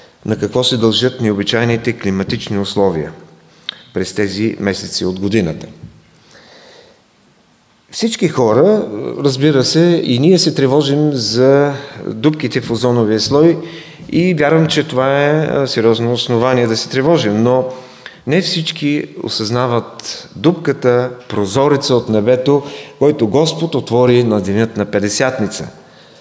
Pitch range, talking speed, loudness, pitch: 115-145 Hz, 115 wpm, -14 LUFS, 125 Hz